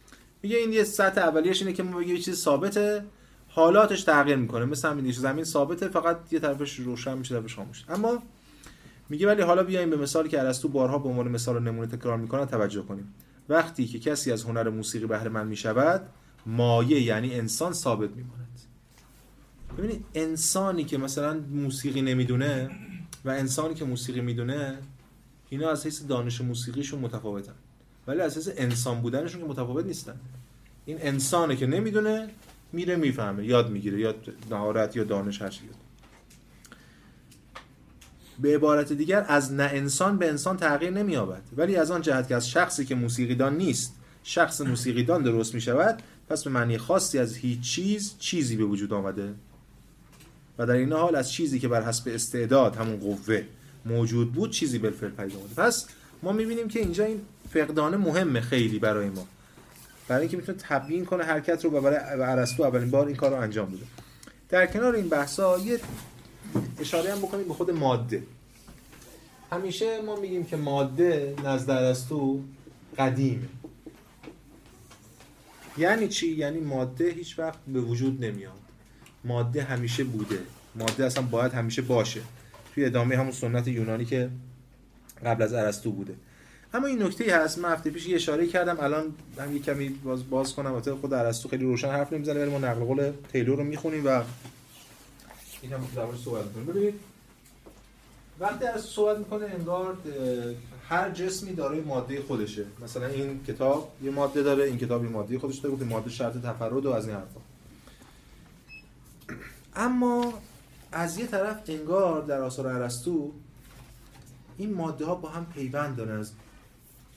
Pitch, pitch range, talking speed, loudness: 135 Hz, 120-165 Hz, 160 wpm, -27 LUFS